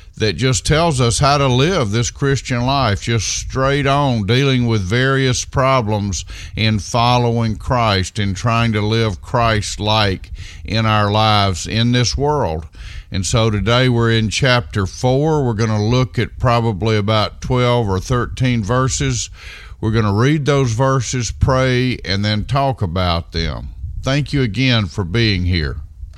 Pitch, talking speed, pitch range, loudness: 115 Hz, 155 wpm, 100-125 Hz, -16 LUFS